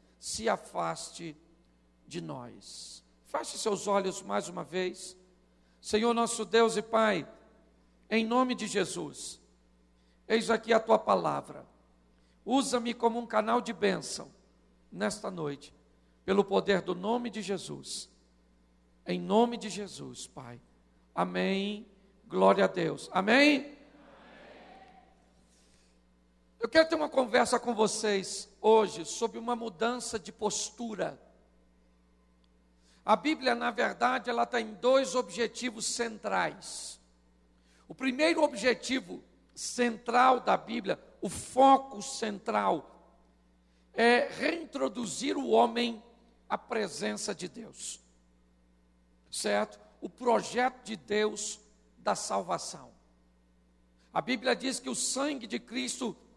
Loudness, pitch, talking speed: -30 LUFS, 205 Hz, 110 wpm